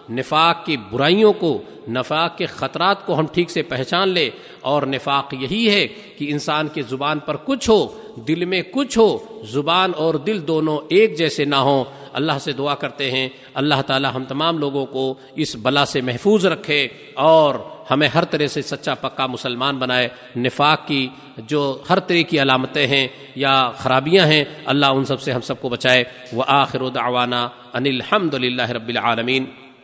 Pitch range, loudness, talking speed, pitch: 130-155 Hz, -19 LUFS, 175 wpm, 140 Hz